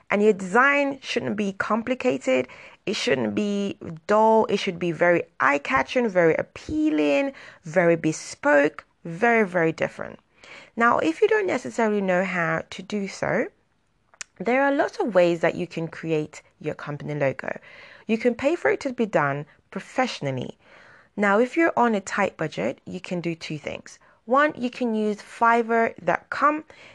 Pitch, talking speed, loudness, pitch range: 195 Hz, 160 wpm, -23 LUFS, 165-240 Hz